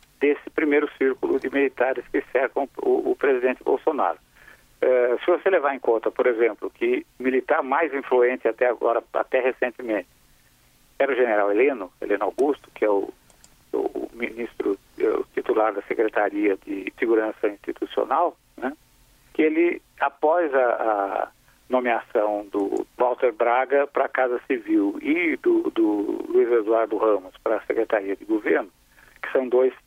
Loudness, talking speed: -23 LUFS, 145 wpm